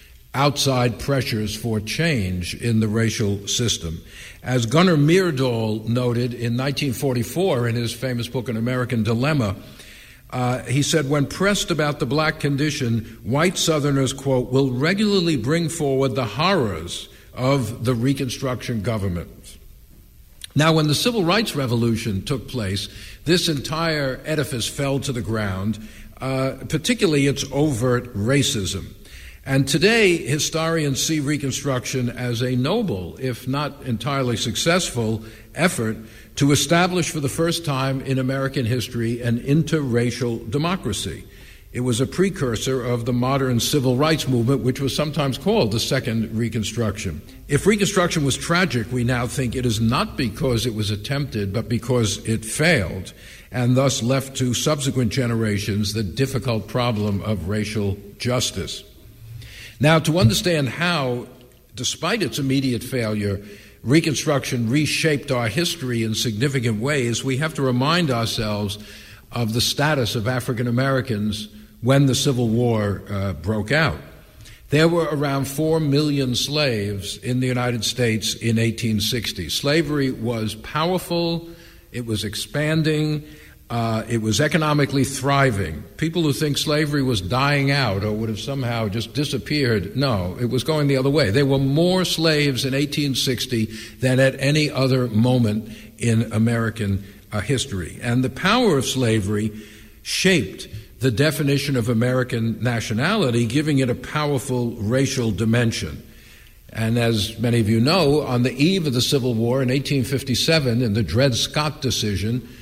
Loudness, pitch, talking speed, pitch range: -21 LUFS, 125 Hz, 140 wpm, 110-145 Hz